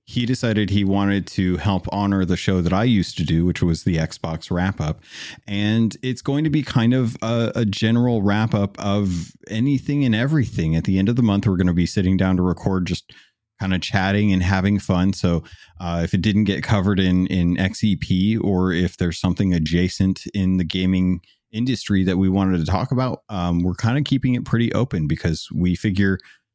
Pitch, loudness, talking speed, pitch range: 95 Hz, -20 LUFS, 210 wpm, 90-110 Hz